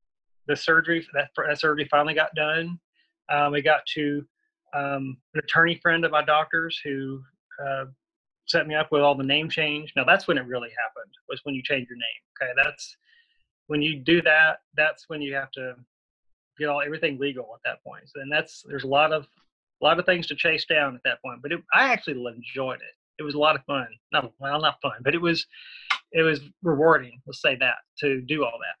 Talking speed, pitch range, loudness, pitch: 220 wpm, 140-160 Hz, -24 LUFS, 150 Hz